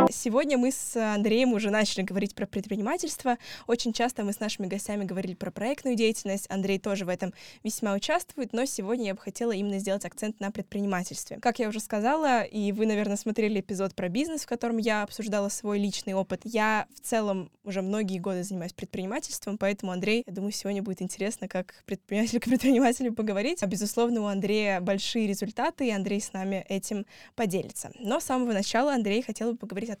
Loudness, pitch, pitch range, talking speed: -29 LUFS, 210 Hz, 195-235 Hz, 190 wpm